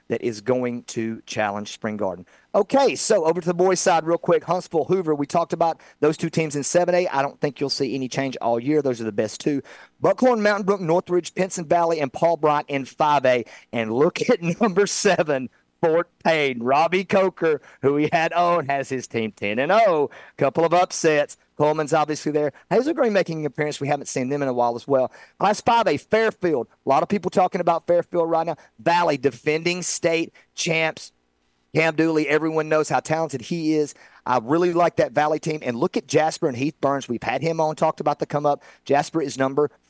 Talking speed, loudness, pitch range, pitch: 210 wpm, -22 LUFS, 135-175 Hz, 155 Hz